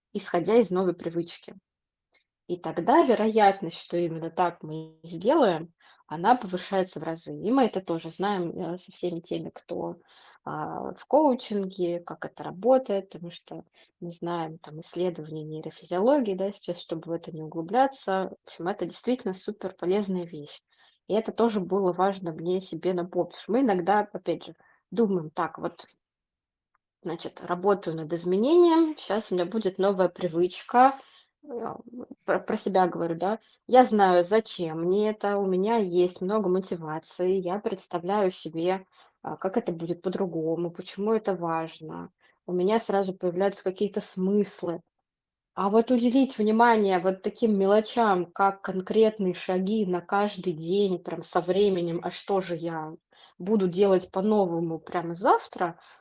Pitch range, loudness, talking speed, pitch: 175-210 Hz, -27 LUFS, 140 wpm, 185 Hz